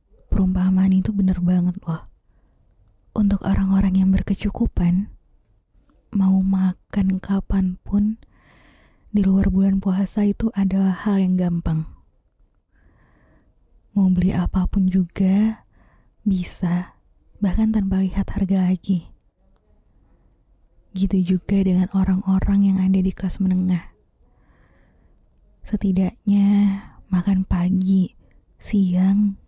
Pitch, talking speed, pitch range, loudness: 190 Hz, 90 wpm, 180-195 Hz, -20 LUFS